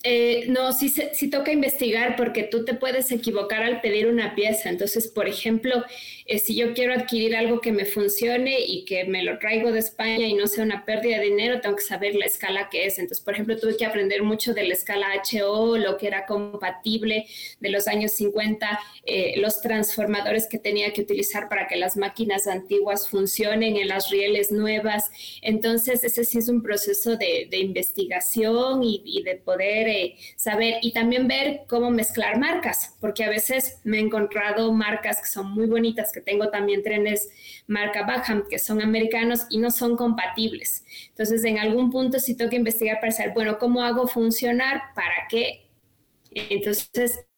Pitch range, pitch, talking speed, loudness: 205-235 Hz, 220 Hz, 185 wpm, -23 LUFS